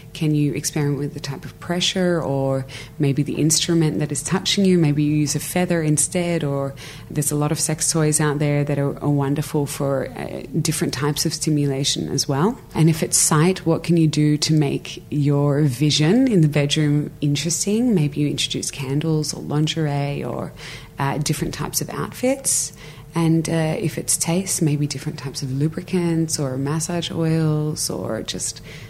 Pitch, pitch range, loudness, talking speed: 150 Hz, 145-165 Hz, -20 LUFS, 180 wpm